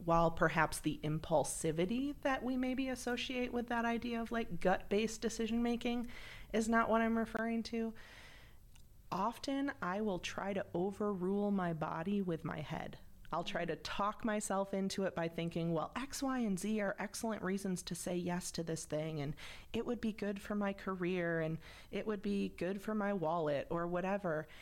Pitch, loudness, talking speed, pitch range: 200 Hz, -38 LUFS, 185 wpm, 170-225 Hz